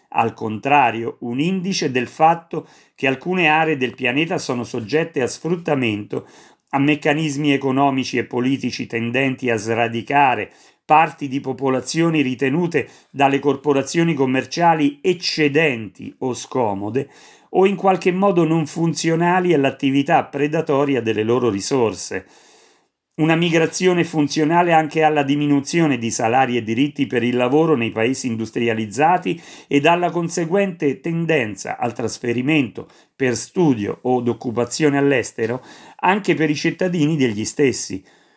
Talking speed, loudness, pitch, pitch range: 120 wpm, -19 LUFS, 145 Hz, 125-165 Hz